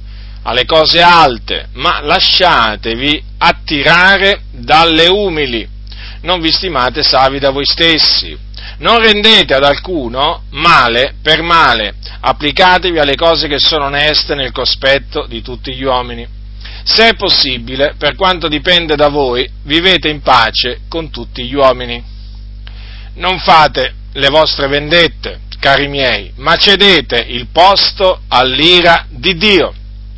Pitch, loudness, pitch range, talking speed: 140 Hz, -9 LUFS, 115-165 Hz, 125 wpm